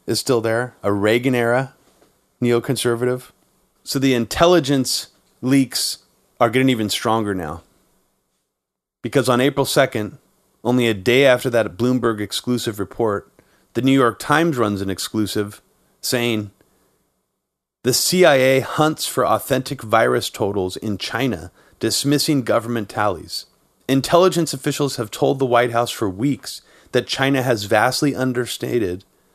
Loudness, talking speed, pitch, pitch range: -19 LUFS, 125 wpm, 125 Hz, 110-135 Hz